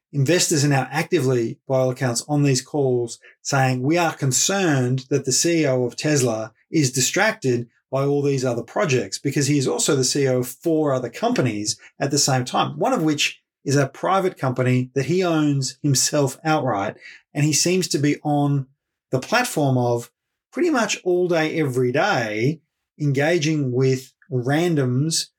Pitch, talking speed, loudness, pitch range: 140 Hz, 165 wpm, -21 LUFS, 130-155 Hz